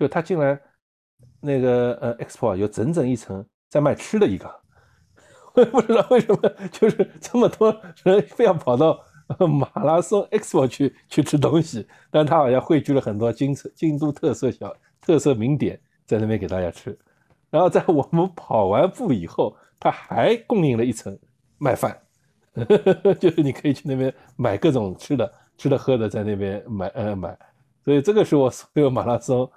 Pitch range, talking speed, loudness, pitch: 120-170 Hz, 270 characters per minute, -21 LUFS, 140 Hz